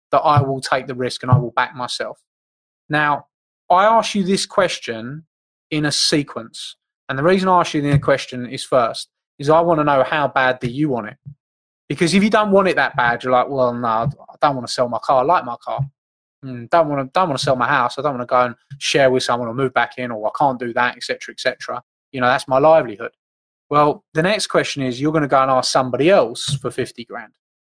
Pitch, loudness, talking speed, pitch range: 135 Hz, -18 LUFS, 255 wpm, 125-155 Hz